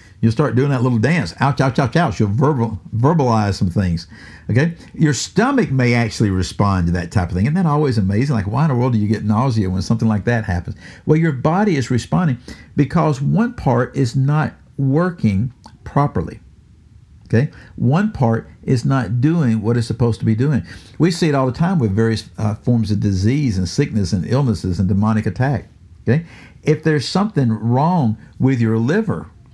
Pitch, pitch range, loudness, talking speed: 120 Hz, 105-145 Hz, -18 LUFS, 195 wpm